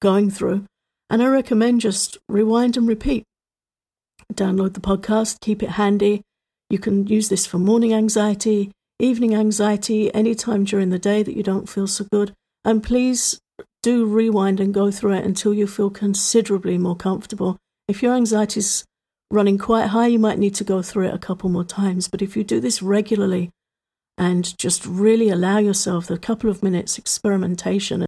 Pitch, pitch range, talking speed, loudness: 205 Hz, 195-220 Hz, 175 wpm, -20 LUFS